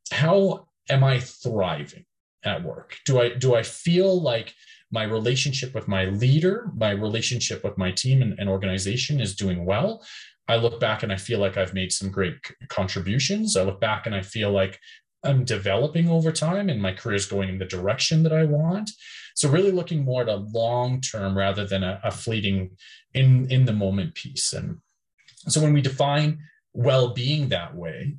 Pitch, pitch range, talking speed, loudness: 120 Hz, 100-145 Hz, 185 wpm, -24 LUFS